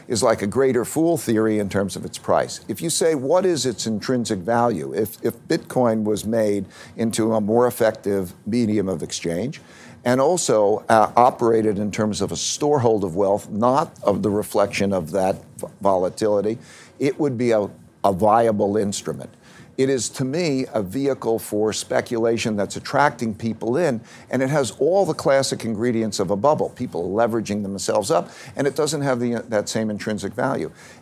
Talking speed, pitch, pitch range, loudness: 180 wpm, 115 Hz, 105-130 Hz, -21 LUFS